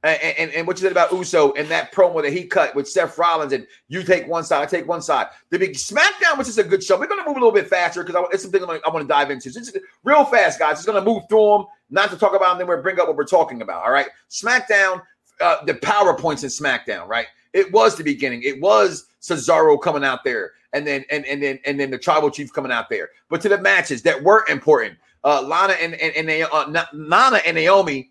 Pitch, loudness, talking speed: 185 Hz, -18 LUFS, 270 wpm